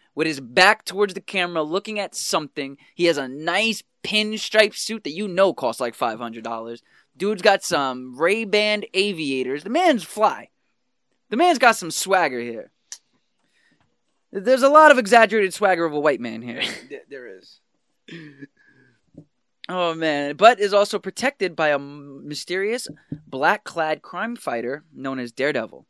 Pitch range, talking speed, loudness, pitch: 145-215 Hz, 145 wpm, -20 LUFS, 190 Hz